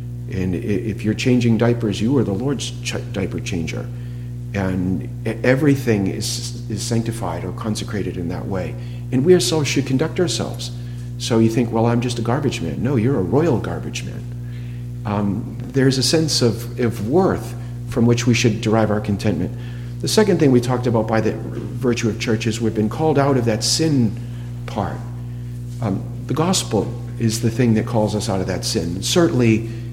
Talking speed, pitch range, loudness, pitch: 185 wpm, 115-120 Hz, -20 LUFS, 120 Hz